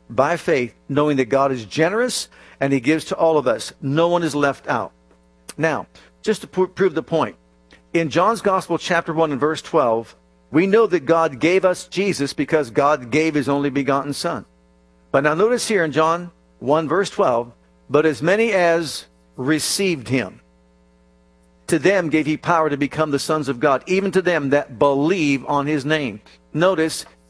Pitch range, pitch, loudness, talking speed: 125-170 Hz, 150 Hz, -19 LUFS, 180 wpm